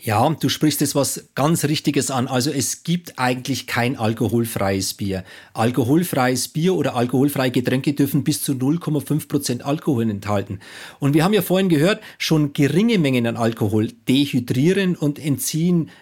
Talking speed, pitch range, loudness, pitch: 150 wpm, 125-155 Hz, -20 LUFS, 140 Hz